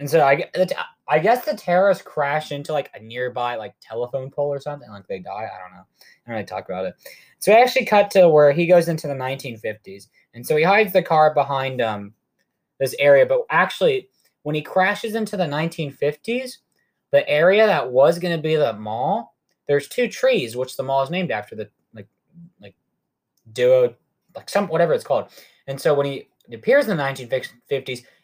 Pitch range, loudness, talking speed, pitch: 135-205 Hz, -20 LUFS, 200 wpm, 155 Hz